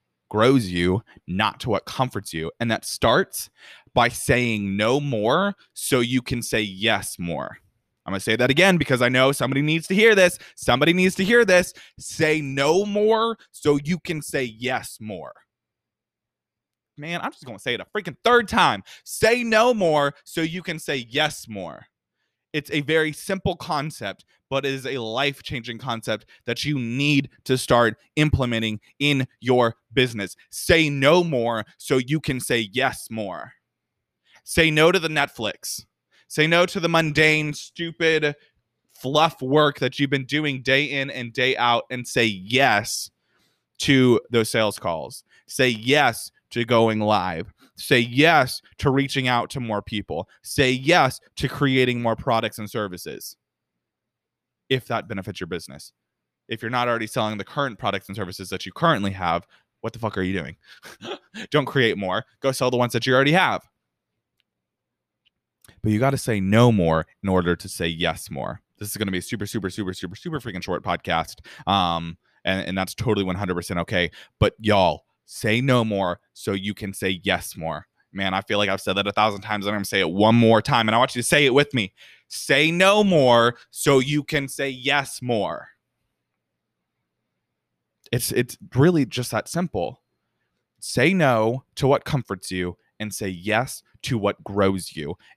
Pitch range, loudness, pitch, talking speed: 105-145 Hz, -22 LUFS, 125 Hz, 180 wpm